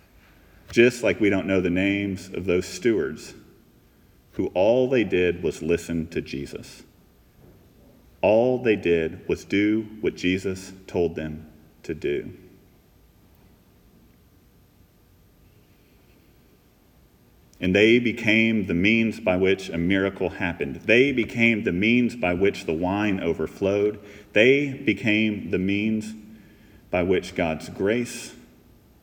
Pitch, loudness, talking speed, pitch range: 95 Hz, -23 LUFS, 115 wpm, 85-110 Hz